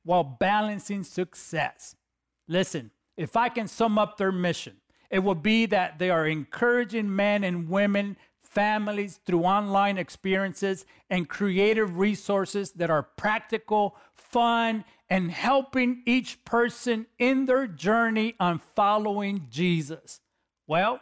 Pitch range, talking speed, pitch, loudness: 180-225 Hz, 125 wpm, 200 Hz, -26 LUFS